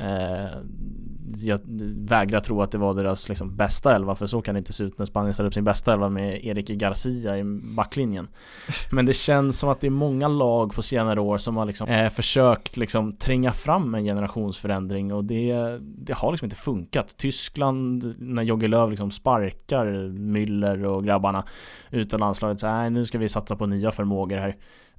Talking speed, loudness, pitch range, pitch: 185 wpm, -24 LUFS, 100-115 Hz, 105 Hz